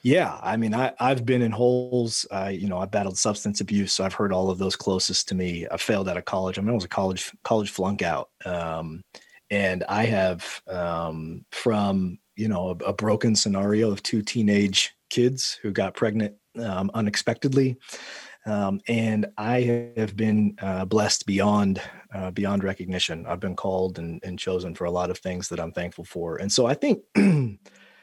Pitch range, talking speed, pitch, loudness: 95-110 Hz, 190 wpm, 100 Hz, -25 LUFS